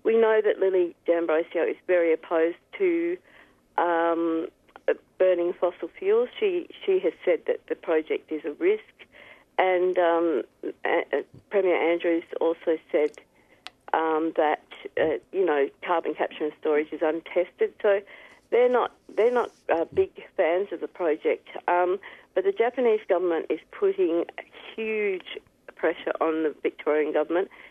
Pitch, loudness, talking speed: 195 Hz, -26 LUFS, 145 wpm